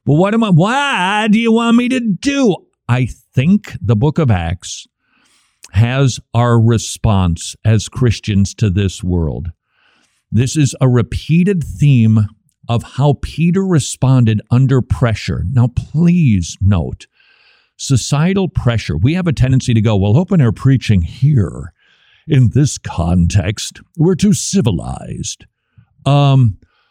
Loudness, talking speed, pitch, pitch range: -14 LUFS, 130 wpm, 125 Hz, 105-155 Hz